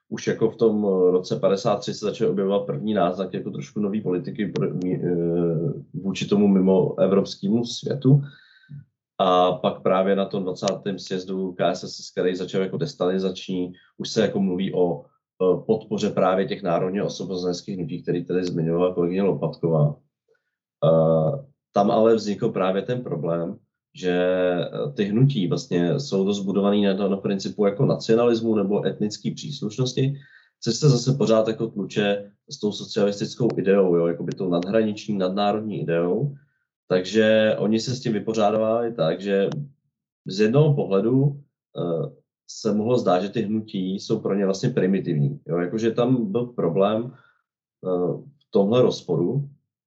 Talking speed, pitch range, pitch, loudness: 140 wpm, 90-120 Hz, 100 Hz, -23 LUFS